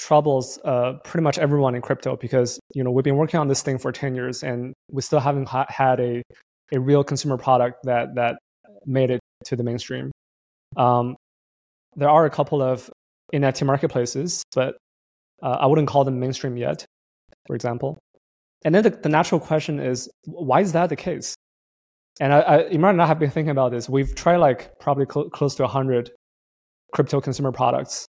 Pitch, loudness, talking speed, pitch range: 135 Hz, -22 LUFS, 190 wpm, 125-145 Hz